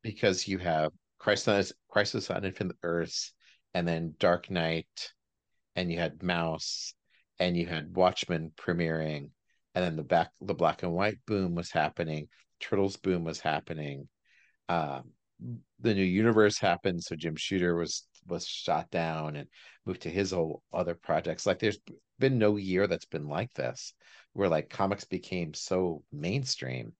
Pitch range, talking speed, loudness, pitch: 80-95 Hz, 155 wpm, -31 LUFS, 85 Hz